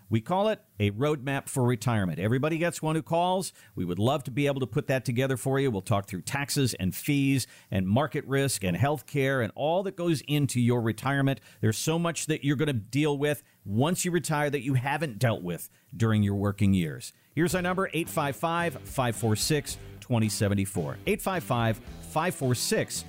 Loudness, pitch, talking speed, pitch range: -28 LUFS, 135 Hz, 185 wpm, 110-155 Hz